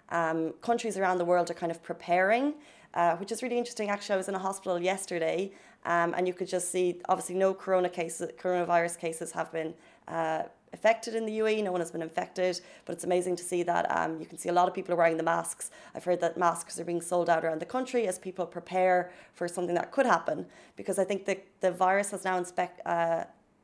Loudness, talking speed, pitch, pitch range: -30 LUFS, 235 wpm, 180 Hz, 170-190 Hz